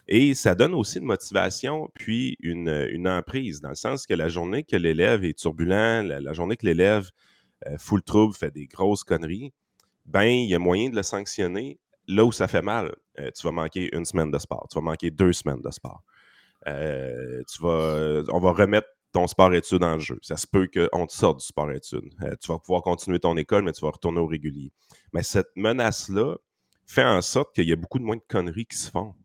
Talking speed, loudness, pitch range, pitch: 220 wpm, -25 LUFS, 80-105 Hz, 90 Hz